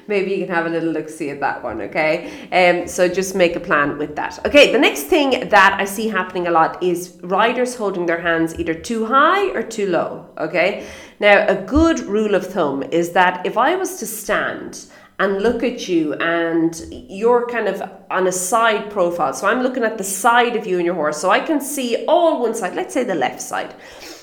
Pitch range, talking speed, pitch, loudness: 175-240 Hz, 225 wpm, 195 Hz, -18 LUFS